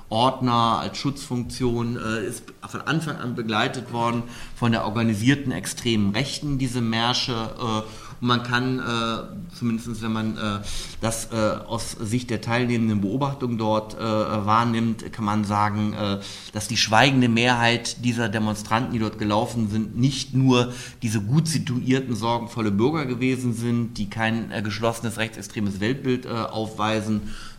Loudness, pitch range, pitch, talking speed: -24 LUFS, 110-125 Hz, 115 Hz, 145 wpm